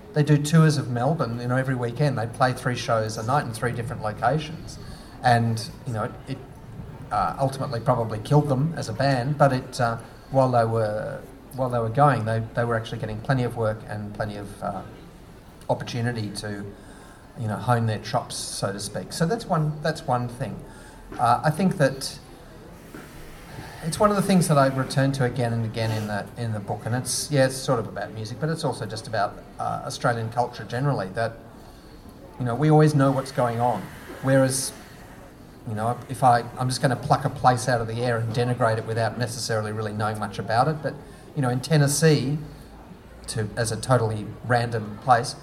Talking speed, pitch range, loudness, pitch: 200 wpm, 115-140 Hz, -24 LUFS, 125 Hz